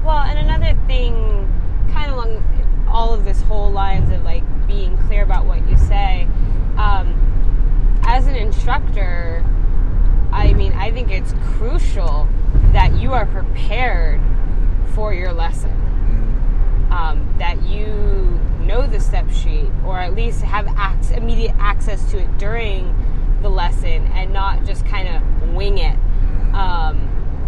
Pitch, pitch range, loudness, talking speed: 90 Hz, 85-100 Hz, -20 LUFS, 140 wpm